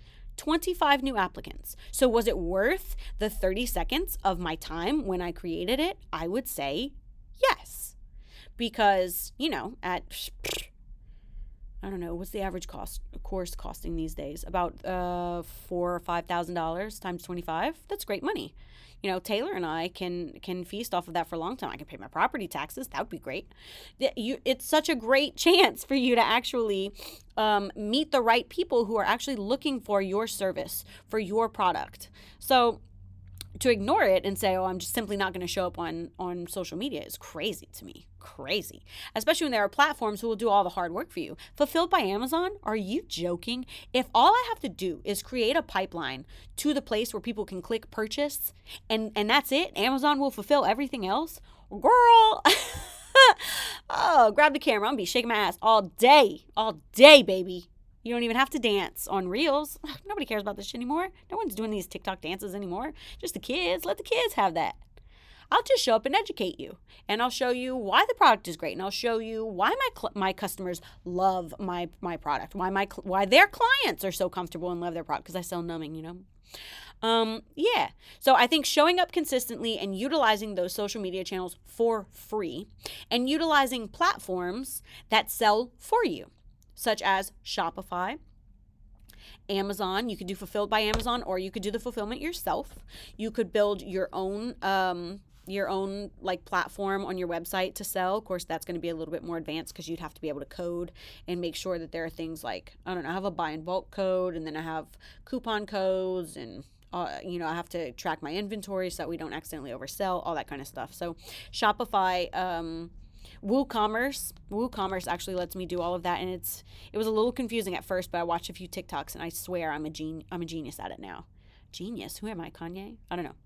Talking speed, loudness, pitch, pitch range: 210 wpm, -27 LUFS, 195 Hz, 175-240 Hz